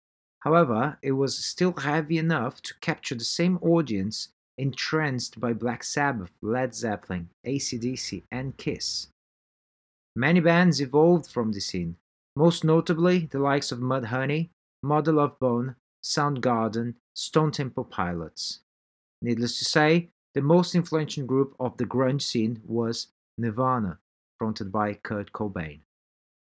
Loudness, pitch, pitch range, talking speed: -26 LUFS, 130 Hz, 110-150 Hz, 125 wpm